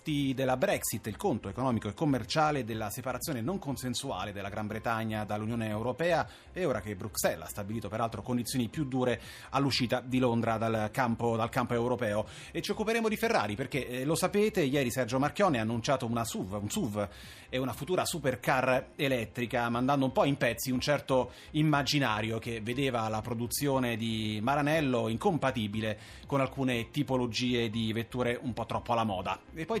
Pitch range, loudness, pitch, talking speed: 115-135 Hz, -31 LUFS, 125 Hz, 170 wpm